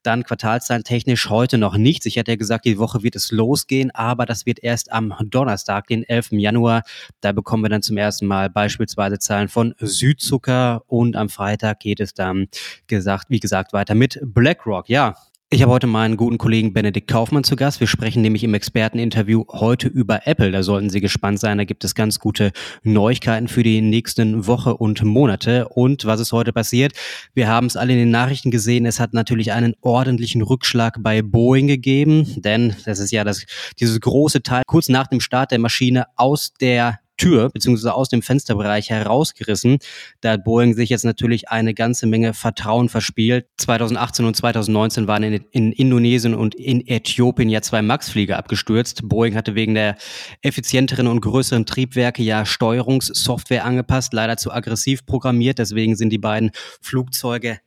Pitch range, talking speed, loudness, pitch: 110-125 Hz, 180 wpm, -18 LUFS, 115 Hz